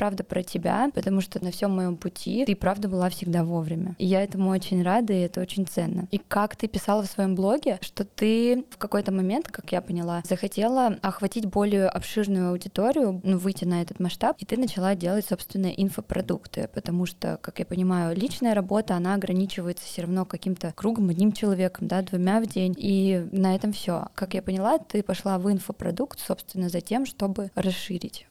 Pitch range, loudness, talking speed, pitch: 185-210 Hz, -26 LUFS, 190 wpm, 195 Hz